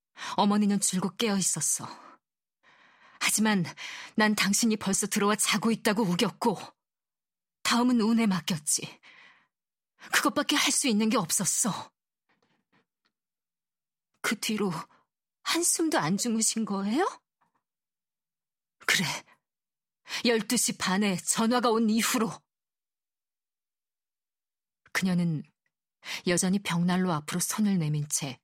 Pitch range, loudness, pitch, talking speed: 185-235 Hz, -27 LUFS, 210 Hz, 200 characters per minute